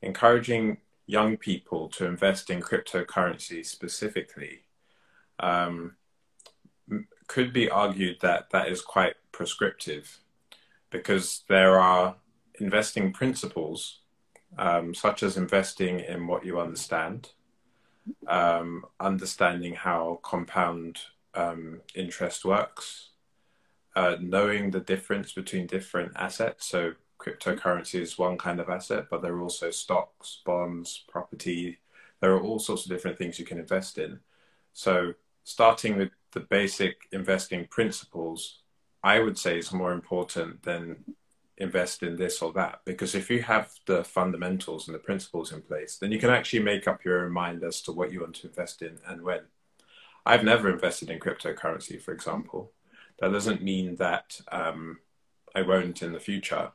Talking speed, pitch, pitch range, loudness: 145 wpm, 90 Hz, 85-100 Hz, -28 LUFS